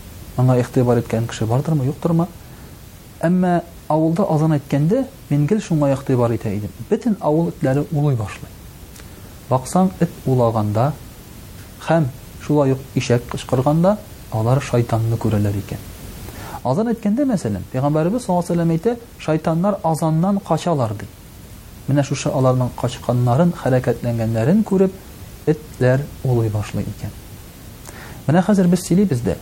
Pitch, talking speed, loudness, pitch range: 130 Hz, 120 wpm, -19 LUFS, 115-165 Hz